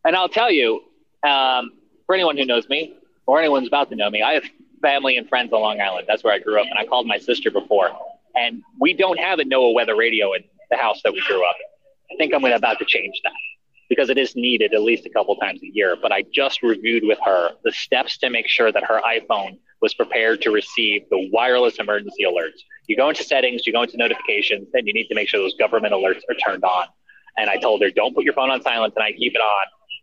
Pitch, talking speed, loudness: 325 Hz, 250 wpm, -19 LUFS